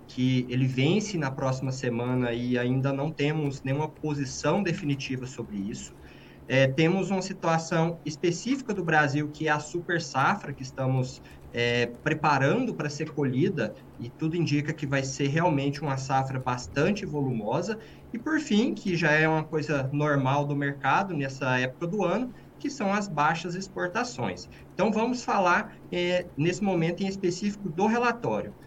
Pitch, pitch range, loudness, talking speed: 150 Hz, 135-180 Hz, -27 LUFS, 155 wpm